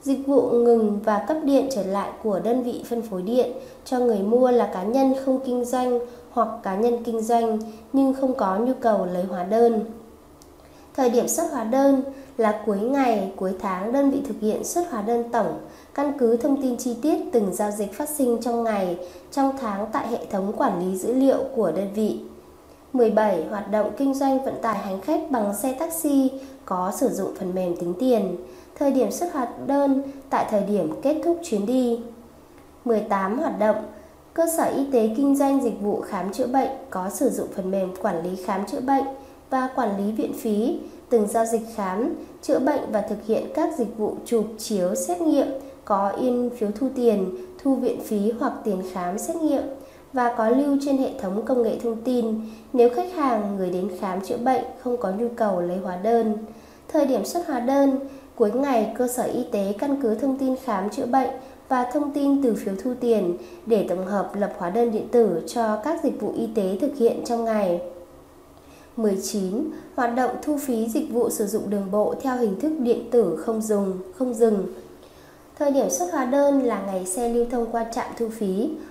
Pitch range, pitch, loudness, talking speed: 210-270 Hz, 235 Hz, -24 LUFS, 205 wpm